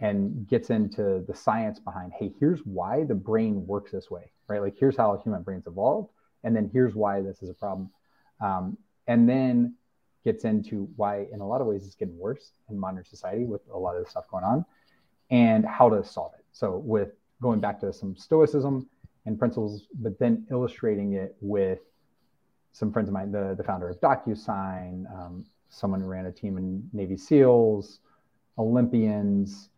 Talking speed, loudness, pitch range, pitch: 185 wpm, -27 LUFS, 95-115 Hz, 105 Hz